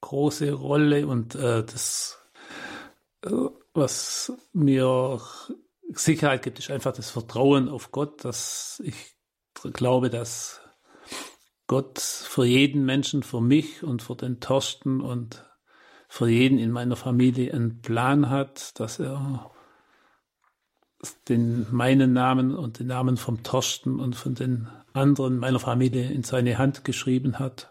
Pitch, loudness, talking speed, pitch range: 130 Hz, -25 LUFS, 130 wpm, 125-140 Hz